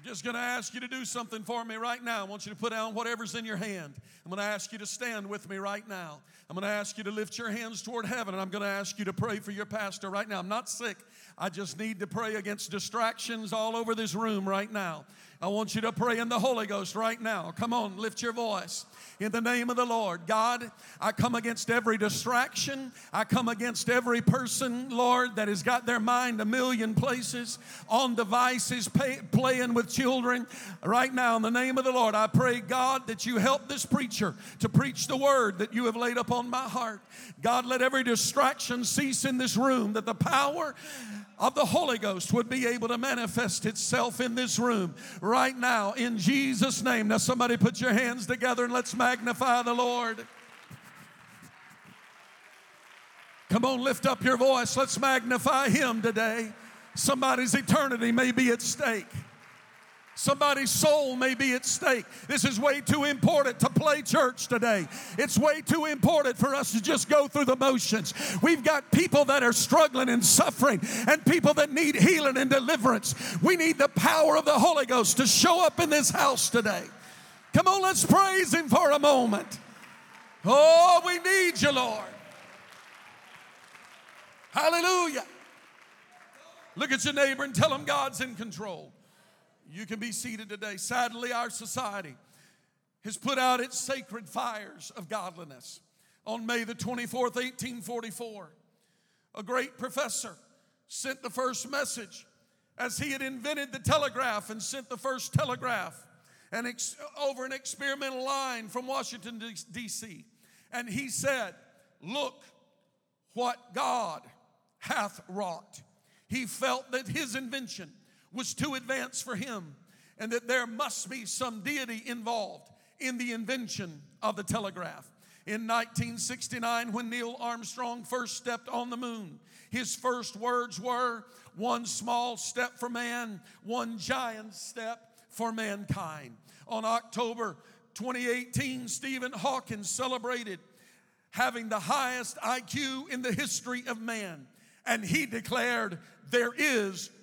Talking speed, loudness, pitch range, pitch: 165 wpm, -28 LUFS, 215-255 Hz, 240 Hz